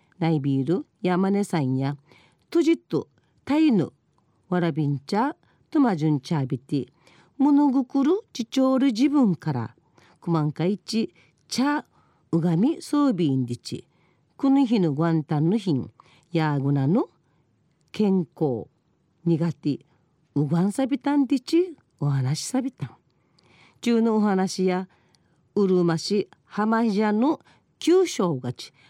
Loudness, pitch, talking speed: -24 LUFS, 180 Hz, 270 characters per minute